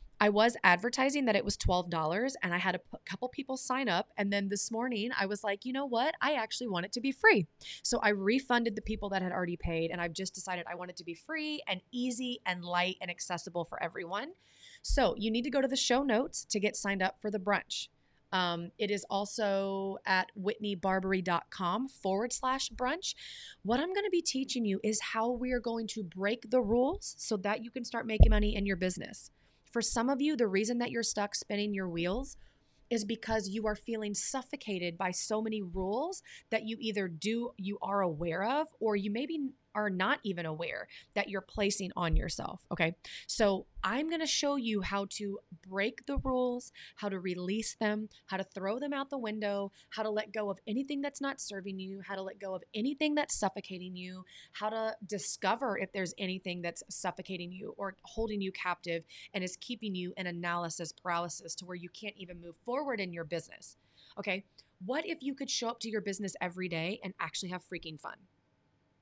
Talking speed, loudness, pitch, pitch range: 210 wpm, -34 LUFS, 205 Hz, 185-240 Hz